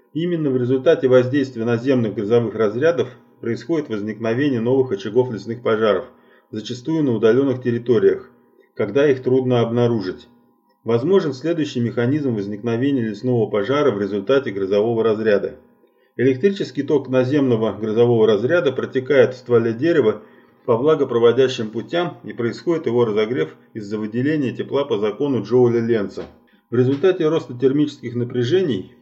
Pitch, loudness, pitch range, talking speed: 125 Hz, -19 LUFS, 115-140 Hz, 120 wpm